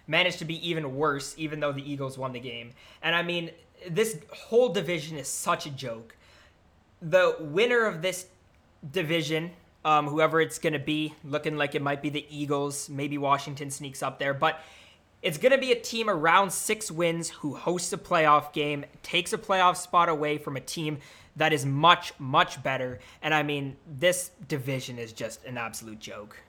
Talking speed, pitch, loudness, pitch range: 190 wpm, 155 Hz, -27 LUFS, 140-175 Hz